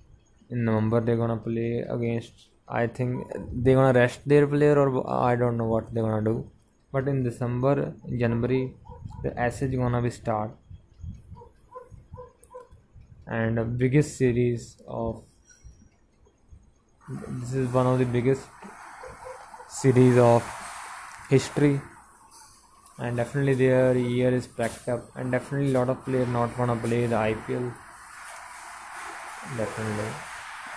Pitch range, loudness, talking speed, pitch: 115-130 Hz, -25 LUFS, 125 wpm, 120 Hz